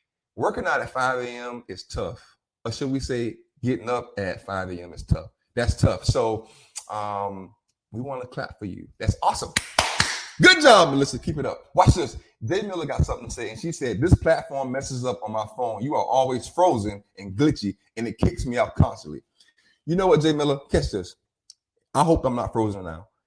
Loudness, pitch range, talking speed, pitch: -23 LUFS, 105-140 Hz, 205 wpm, 120 Hz